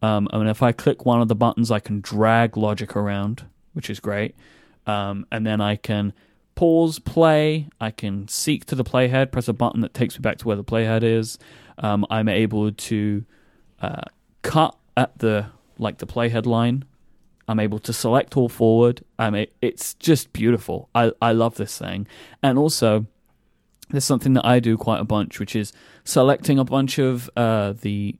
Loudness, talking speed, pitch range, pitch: -21 LUFS, 190 wpm, 105-120 Hz, 115 Hz